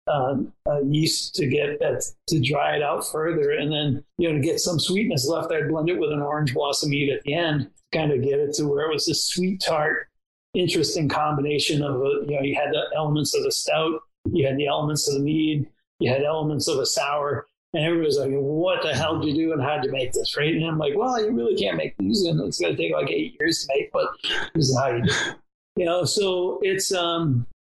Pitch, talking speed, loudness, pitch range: 155 Hz, 250 wpm, -23 LUFS, 145-190 Hz